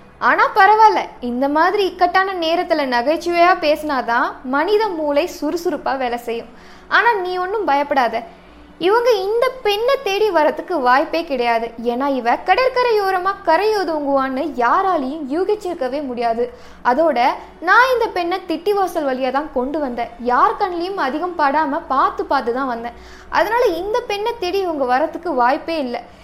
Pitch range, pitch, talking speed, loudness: 265-390 Hz, 325 Hz, 130 wpm, -17 LUFS